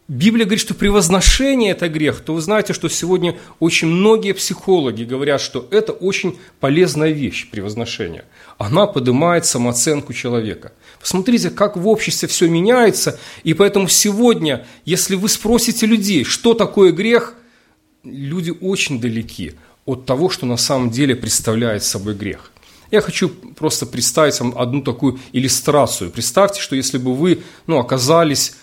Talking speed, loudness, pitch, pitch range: 145 wpm, -16 LUFS, 165 Hz, 130-195 Hz